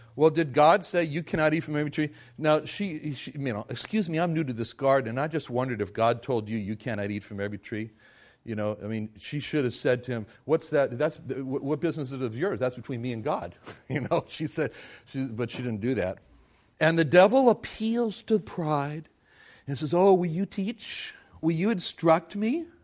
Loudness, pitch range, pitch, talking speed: -27 LUFS, 120-165 Hz, 145 Hz, 225 wpm